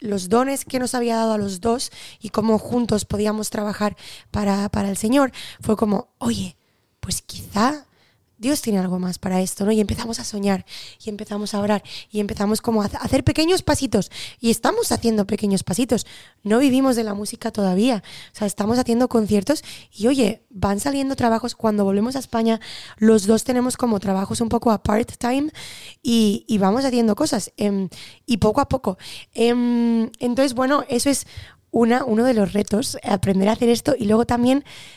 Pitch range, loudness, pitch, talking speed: 205-245 Hz, -21 LUFS, 225 Hz, 180 wpm